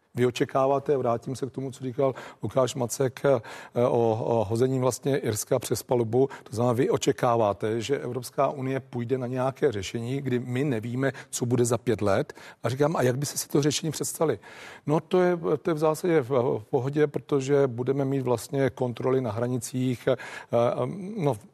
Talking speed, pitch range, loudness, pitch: 175 wpm, 120-140 Hz, -27 LUFS, 130 Hz